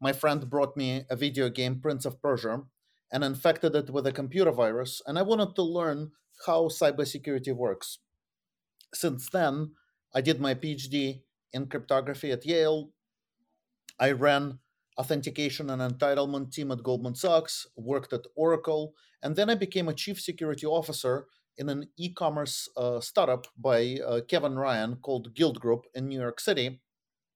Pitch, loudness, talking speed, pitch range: 140 Hz, -29 LUFS, 155 wpm, 130-155 Hz